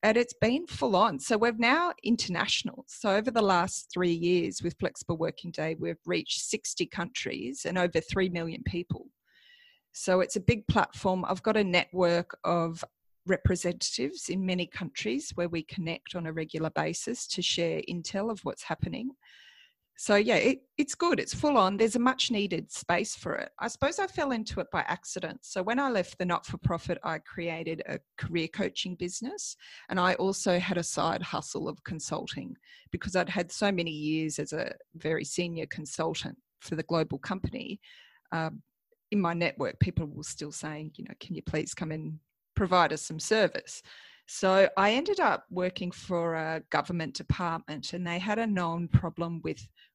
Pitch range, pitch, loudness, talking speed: 165-225 Hz, 180 Hz, -30 LUFS, 180 wpm